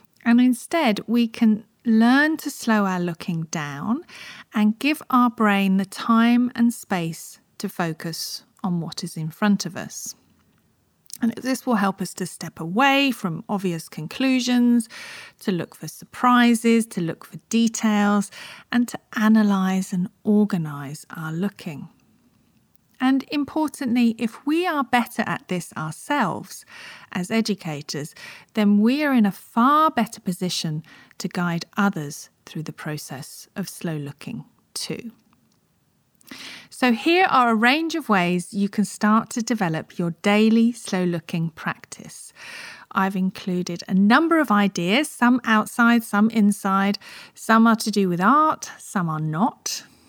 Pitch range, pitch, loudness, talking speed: 180-240 Hz, 210 Hz, -21 LUFS, 140 wpm